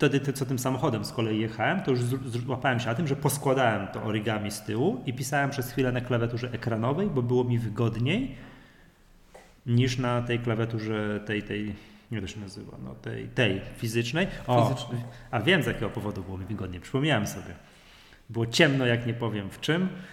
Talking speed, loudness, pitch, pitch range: 185 wpm, -28 LUFS, 120 Hz, 110-130 Hz